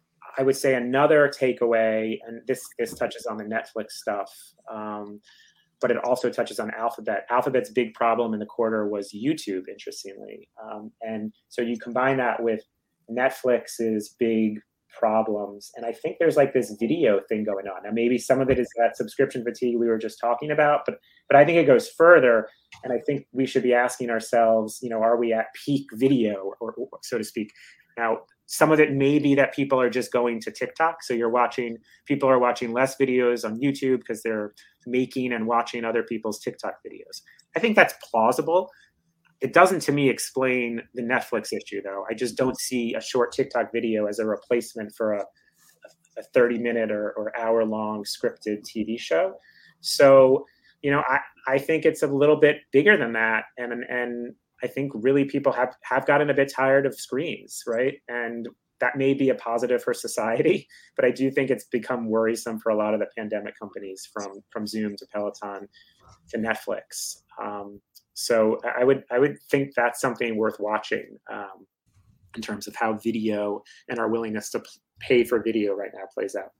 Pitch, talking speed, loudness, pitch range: 120 Hz, 190 wpm, -24 LUFS, 110-135 Hz